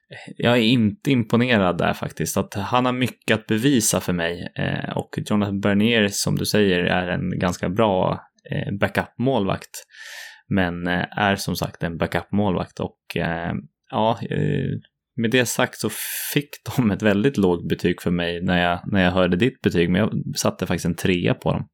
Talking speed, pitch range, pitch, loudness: 180 wpm, 90-120 Hz, 100 Hz, -22 LUFS